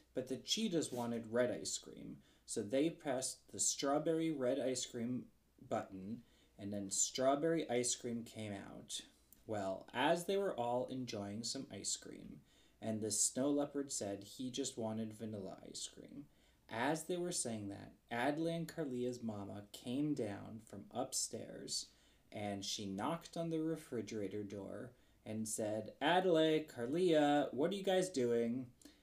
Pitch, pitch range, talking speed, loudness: 125 Hz, 110-150 Hz, 150 wpm, -40 LUFS